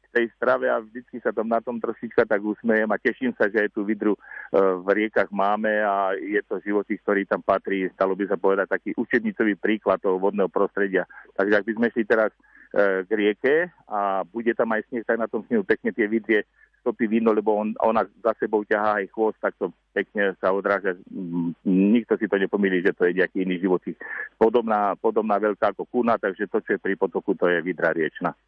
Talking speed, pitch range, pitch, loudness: 210 wpm, 100-110 Hz, 105 Hz, -24 LUFS